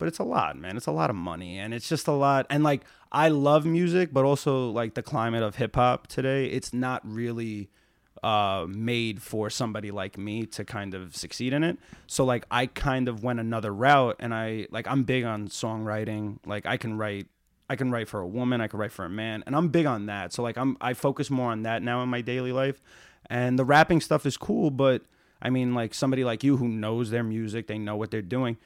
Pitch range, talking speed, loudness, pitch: 110-135 Hz, 240 wpm, -27 LUFS, 120 Hz